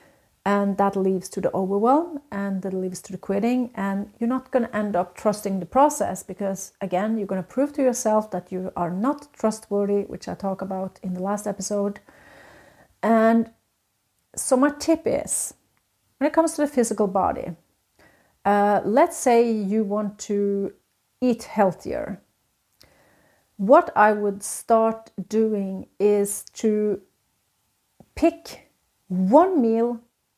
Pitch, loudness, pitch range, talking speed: 210 Hz, -23 LUFS, 195-240 Hz, 145 wpm